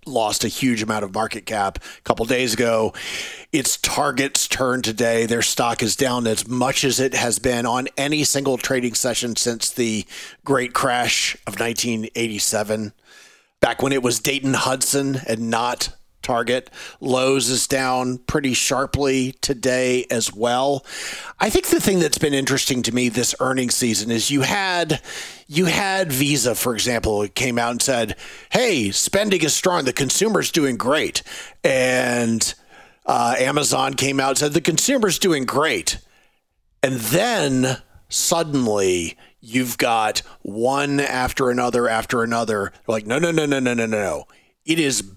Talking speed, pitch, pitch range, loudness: 155 wpm, 125 Hz, 115-135 Hz, -20 LUFS